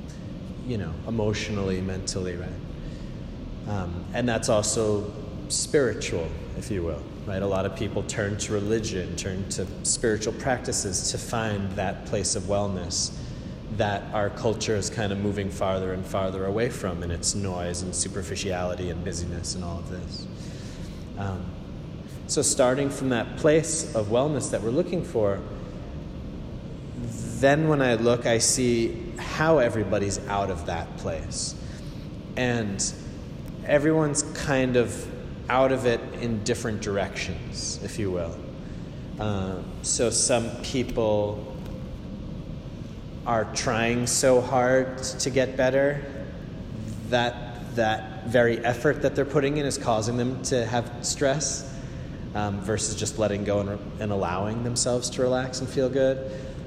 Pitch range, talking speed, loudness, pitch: 95-125 Hz, 140 wpm, -26 LUFS, 110 Hz